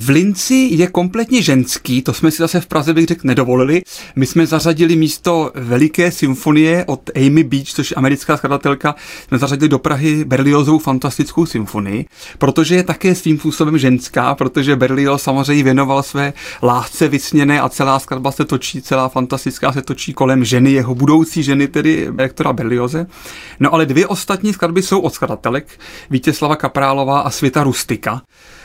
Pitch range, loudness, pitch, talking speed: 135-160 Hz, -14 LUFS, 145 Hz, 160 wpm